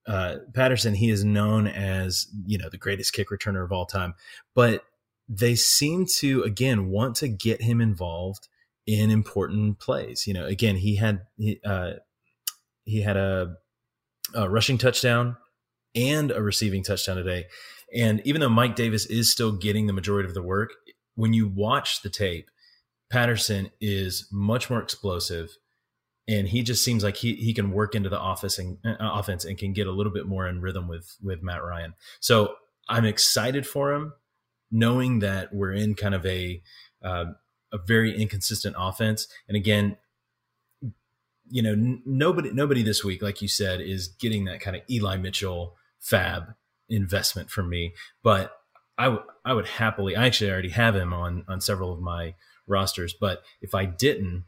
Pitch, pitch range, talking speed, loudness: 105 Hz, 95-115 Hz, 175 wpm, -25 LUFS